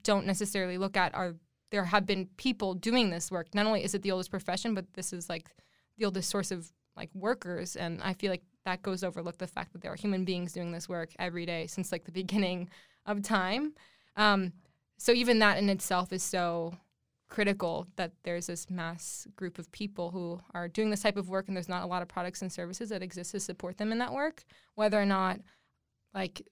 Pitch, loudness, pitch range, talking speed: 185 Hz, -33 LUFS, 175-205 Hz, 220 wpm